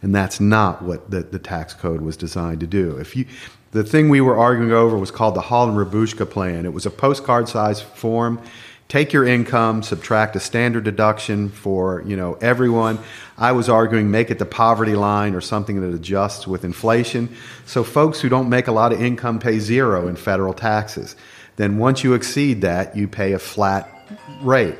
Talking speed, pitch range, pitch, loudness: 195 wpm, 95-120 Hz, 110 Hz, -19 LUFS